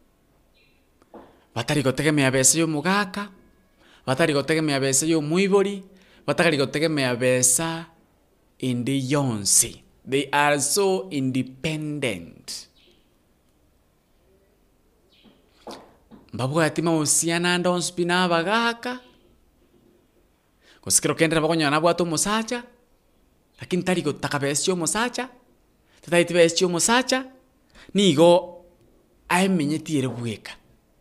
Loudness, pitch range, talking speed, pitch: -22 LUFS, 135-180 Hz, 85 wpm, 160 Hz